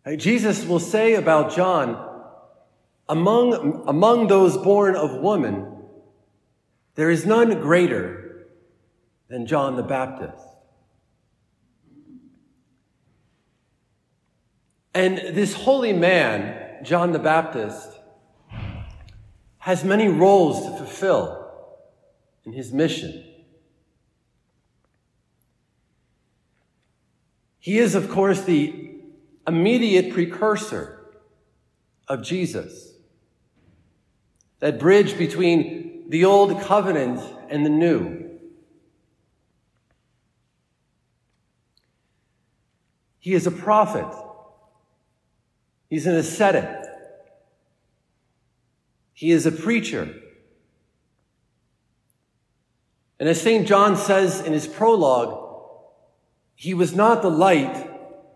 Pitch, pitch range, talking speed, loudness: 185 Hz, 160-210 Hz, 80 wpm, -20 LUFS